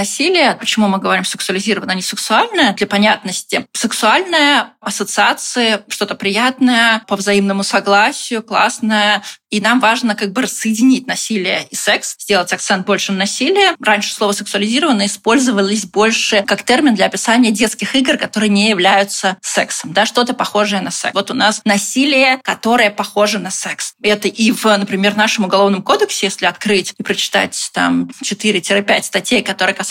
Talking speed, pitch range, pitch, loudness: 155 wpm, 200-240 Hz, 210 Hz, -14 LUFS